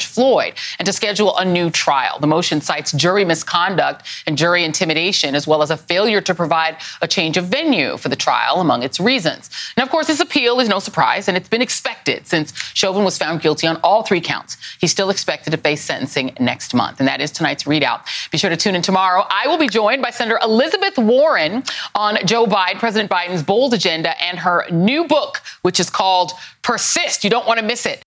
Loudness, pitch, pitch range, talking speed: -16 LUFS, 185 Hz, 165-230 Hz, 215 wpm